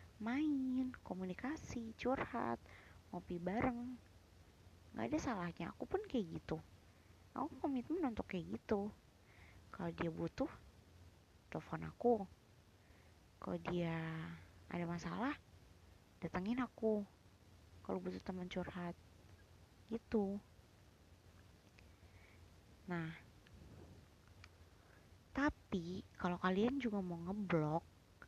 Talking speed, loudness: 85 wpm, -43 LUFS